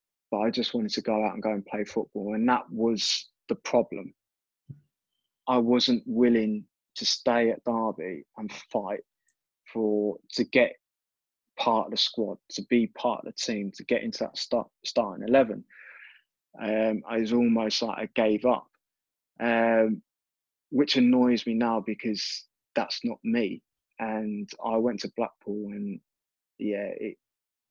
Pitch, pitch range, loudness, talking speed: 115 Hz, 110-125 Hz, -28 LUFS, 155 wpm